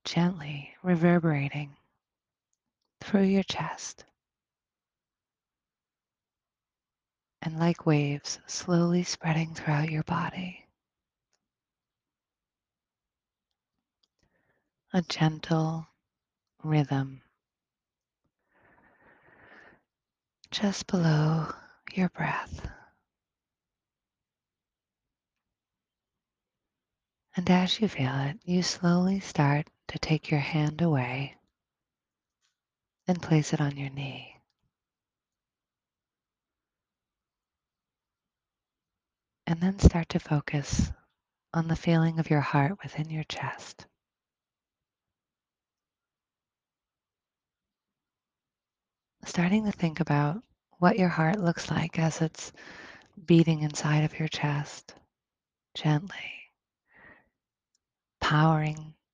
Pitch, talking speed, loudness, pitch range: 160 Hz, 70 wpm, -28 LUFS, 145-175 Hz